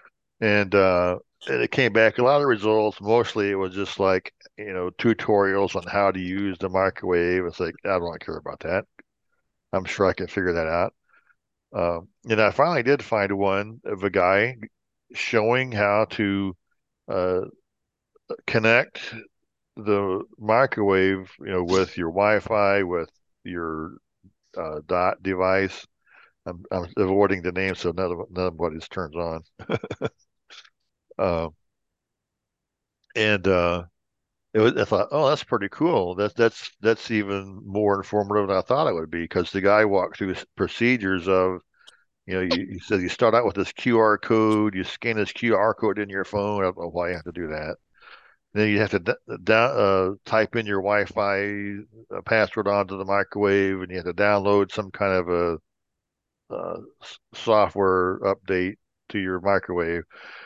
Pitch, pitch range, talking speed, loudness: 100 Hz, 90-105 Hz, 170 wpm, -23 LUFS